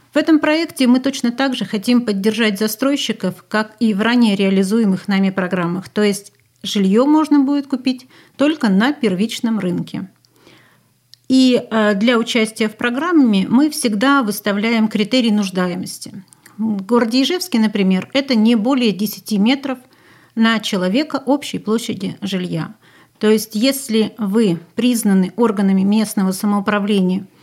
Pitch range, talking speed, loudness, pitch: 200-250 Hz, 125 wpm, -17 LUFS, 220 Hz